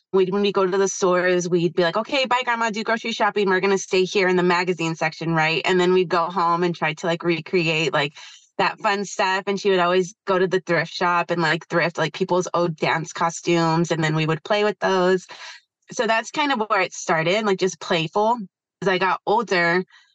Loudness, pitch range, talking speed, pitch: -21 LUFS, 170-200 Hz, 230 wpm, 185 Hz